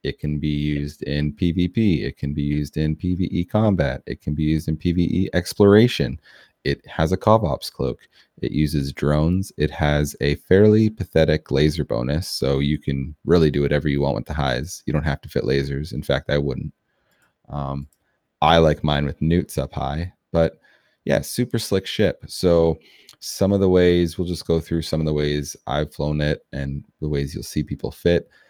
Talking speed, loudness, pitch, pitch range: 195 wpm, -21 LUFS, 75 Hz, 70-85 Hz